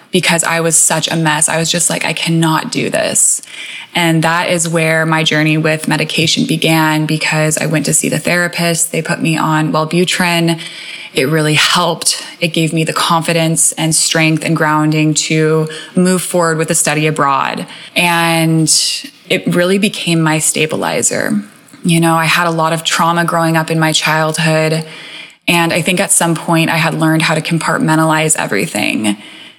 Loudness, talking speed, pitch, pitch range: -12 LUFS, 175 wpm, 160 Hz, 155-170 Hz